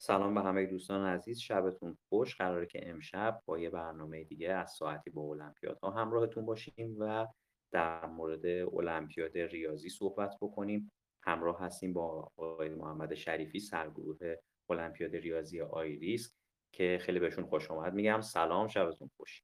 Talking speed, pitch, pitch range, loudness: 145 wpm, 90 Hz, 80-105 Hz, -38 LUFS